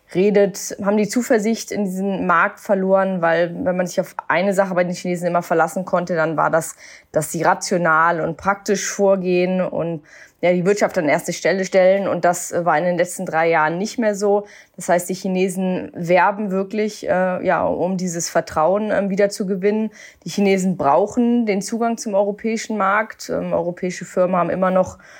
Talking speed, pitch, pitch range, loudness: 185 wpm, 190 Hz, 175-200 Hz, -19 LUFS